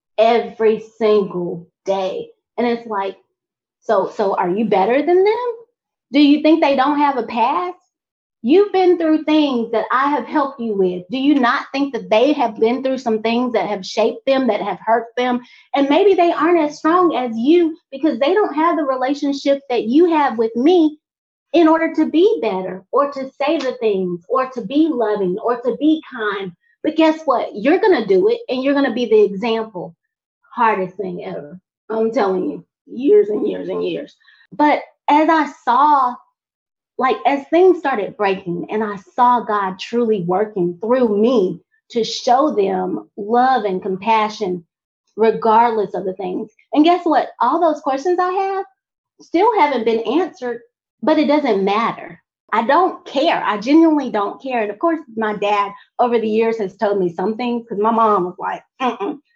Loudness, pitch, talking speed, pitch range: -17 LUFS, 245 Hz, 185 wpm, 215-310 Hz